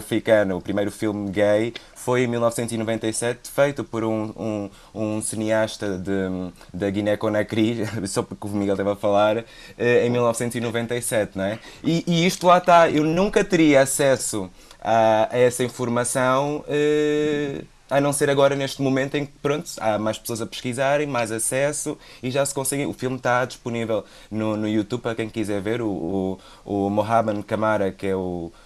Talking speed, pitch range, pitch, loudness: 170 wpm, 105-135 Hz, 115 Hz, -22 LUFS